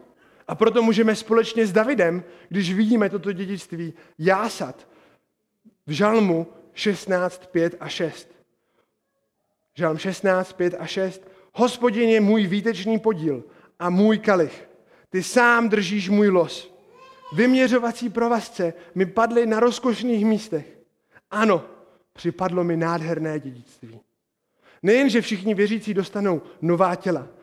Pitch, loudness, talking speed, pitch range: 195 Hz, -22 LUFS, 115 wpm, 170-225 Hz